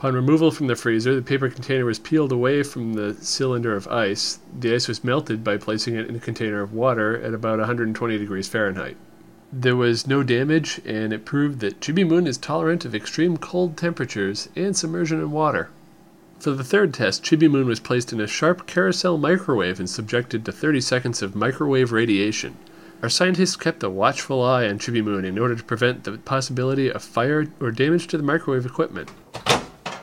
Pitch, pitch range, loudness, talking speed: 130 Hz, 115-155 Hz, -22 LUFS, 195 wpm